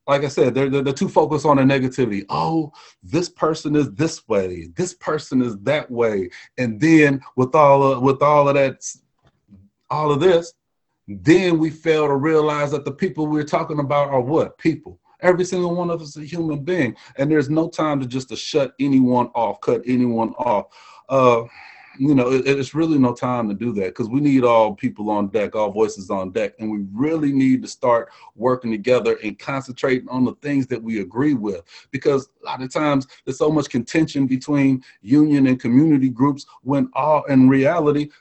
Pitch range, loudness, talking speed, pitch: 125-150 Hz, -19 LUFS, 200 wpm, 135 Hz